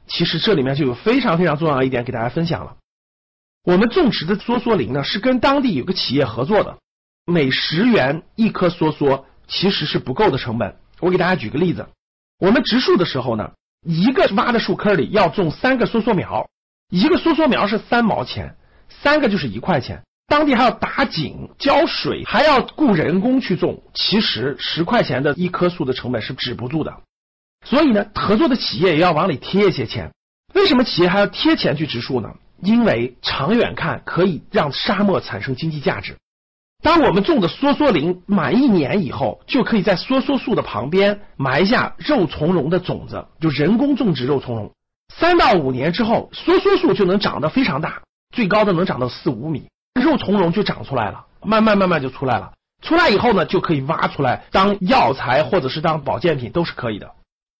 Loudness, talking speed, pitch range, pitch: -18 LUFS, 295 characters per minute, 150-230 Hz, 185 Hz